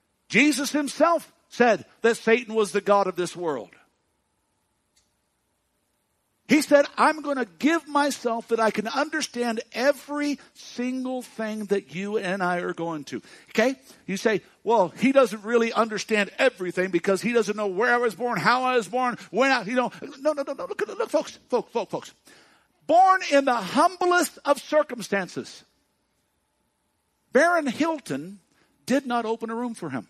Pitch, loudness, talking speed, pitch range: 240 Hz, -24 LUFS, 165 wpm, 210-285 Hz